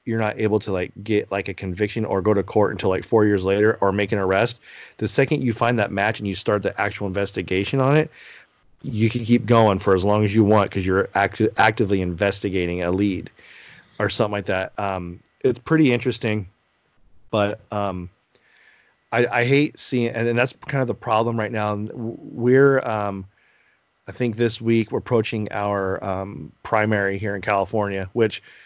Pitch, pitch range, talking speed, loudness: 105 Hz, 100-115 Hz, 190 wpm, -21 LUFS